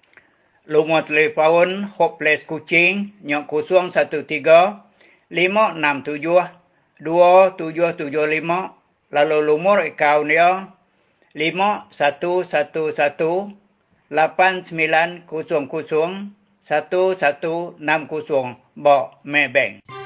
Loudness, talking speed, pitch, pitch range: -18 LUFS, 50 wpm, 160 Hz, 150-180 Hz